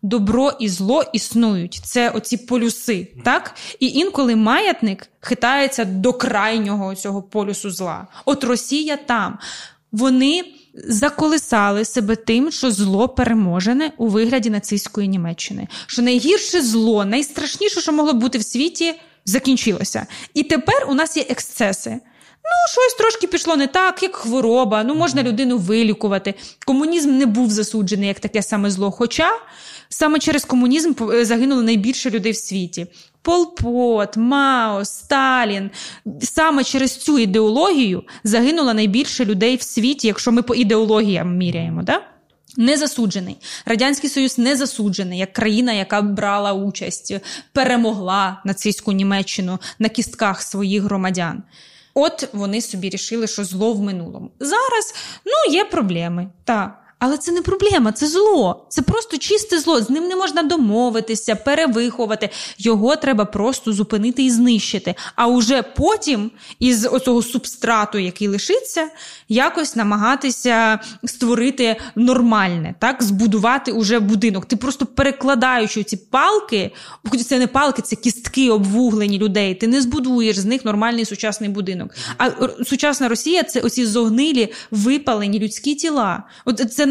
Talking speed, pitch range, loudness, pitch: 135 wpm, 210-275 Hz, -18 LUFS, 235 Hz